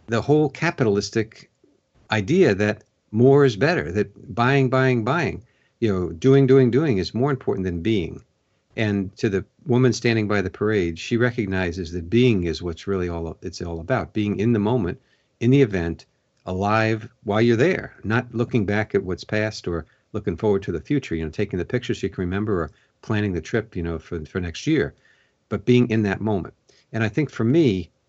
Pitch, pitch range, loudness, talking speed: 110 Hz, 95-125 Hz, -22 LUFS, 195 wpm